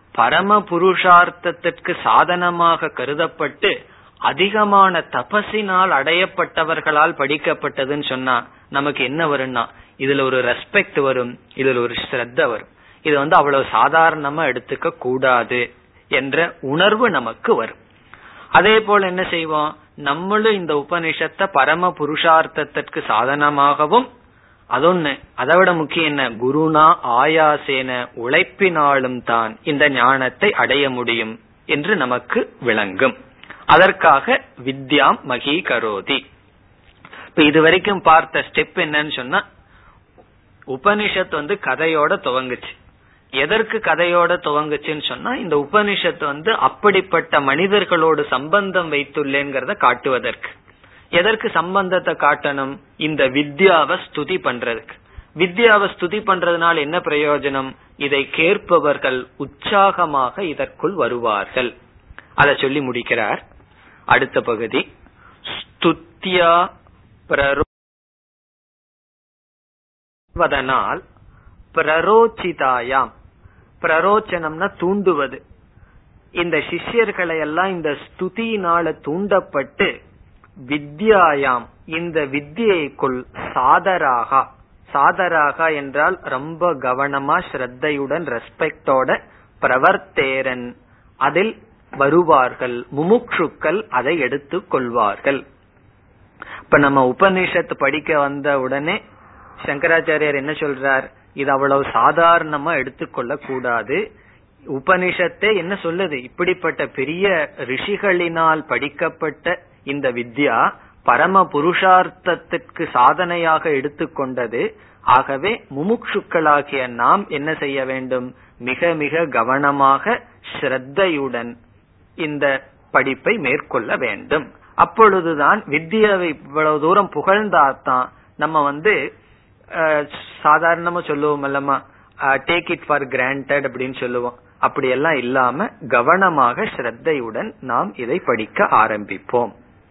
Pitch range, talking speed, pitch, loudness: 130-175 Hz, 80 wpm, 150 Hz, -17 LUFS